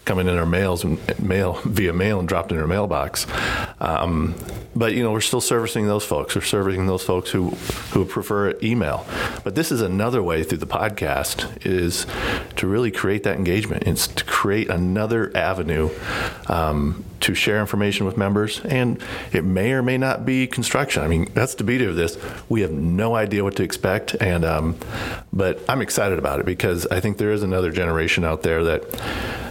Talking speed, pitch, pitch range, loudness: 190 wpm, 95 Hz, 85-110 Hz, -22 LUFS